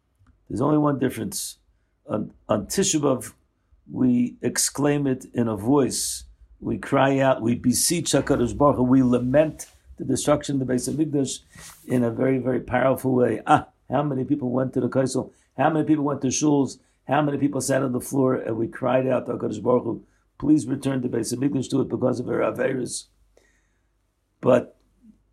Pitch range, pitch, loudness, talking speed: 120-145 Hz, 130 Hz, -23 LUFS, 175 wpm